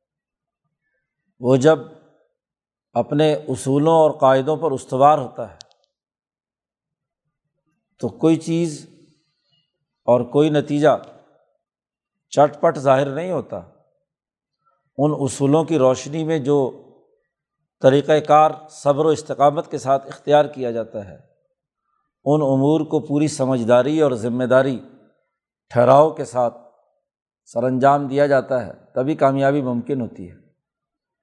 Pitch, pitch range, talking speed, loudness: 150 Hz, 135-155 Hz, 115 wpm, -18 LUFS